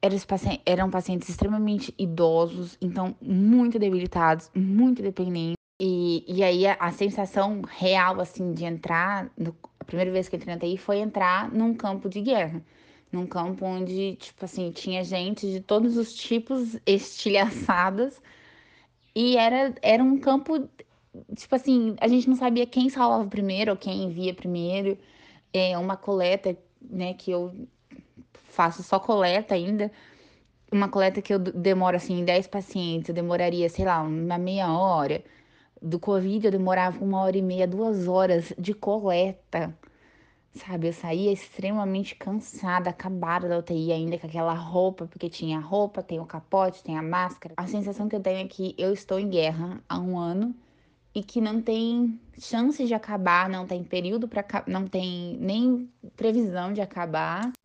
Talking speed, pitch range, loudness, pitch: 160 wpm, 180-210 Hz, -26 LUFS, 190 Hz